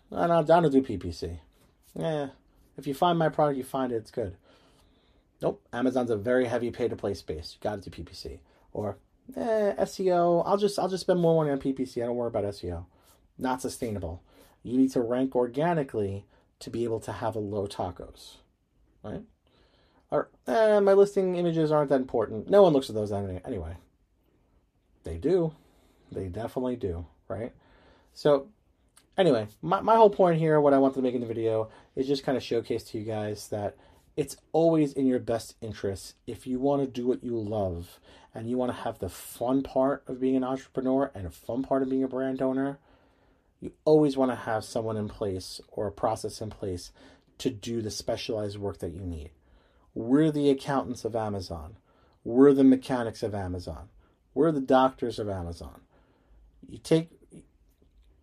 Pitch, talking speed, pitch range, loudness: 120 Hz, 185 wpm, 100-140 Hz, -27 LUFS